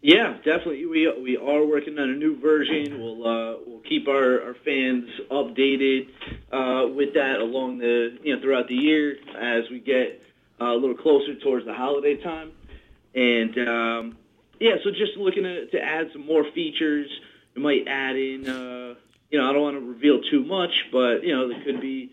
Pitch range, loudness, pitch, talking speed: 125-155 Hz, -23 LUFS, 135 Hz, 195 wpm